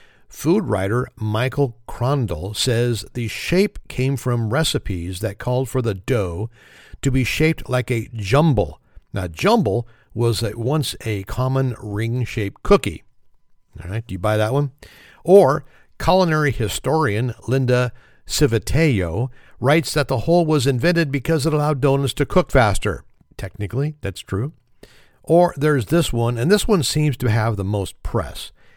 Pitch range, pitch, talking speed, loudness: 110-145 Hz, 125 Hz, 150 wpm, -20 LUFS